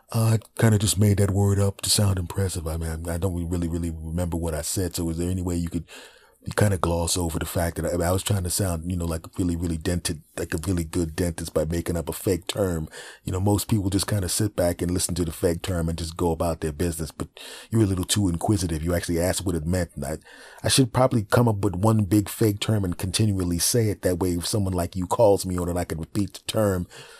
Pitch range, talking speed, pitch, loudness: 85-100 Hz, 270 wpm, 90 Hz, -25 LUFS